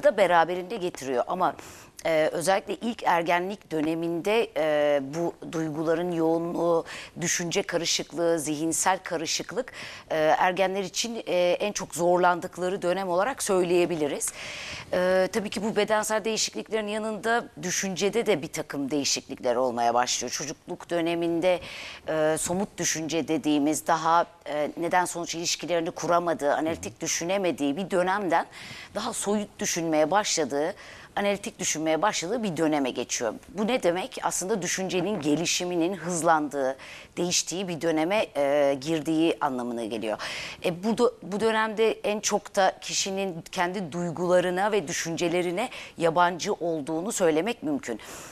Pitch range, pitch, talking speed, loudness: 160-195 Hz, 175 Hz, 120 wpm, -26 LUFS